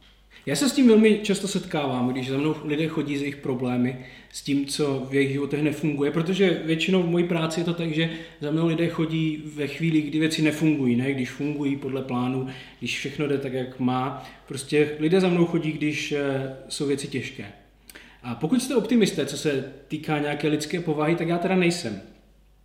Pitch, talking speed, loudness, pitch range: 150 Hz, 195 wpm, -24 LUFS, 135-165 Hz